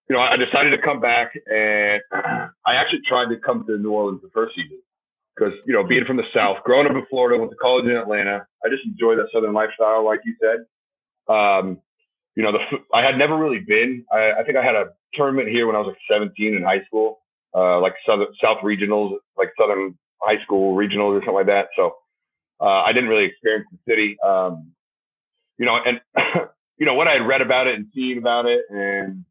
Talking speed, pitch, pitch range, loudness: 220 wpm, 115 Hz, 105-155 Hz, -19 LUFS